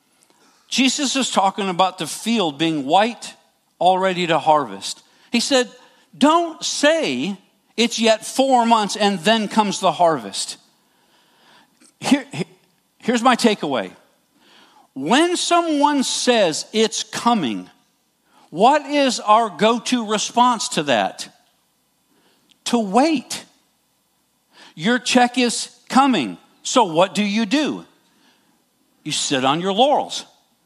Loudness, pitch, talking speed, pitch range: -18 LUFS, 235 Hz, 110 wpm, 205-265 Hz